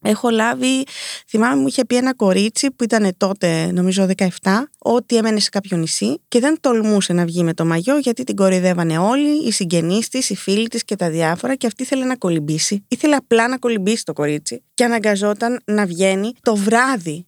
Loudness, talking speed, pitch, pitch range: -18 LUFS, 195 wpm, 215 Hz, 185-245 Hz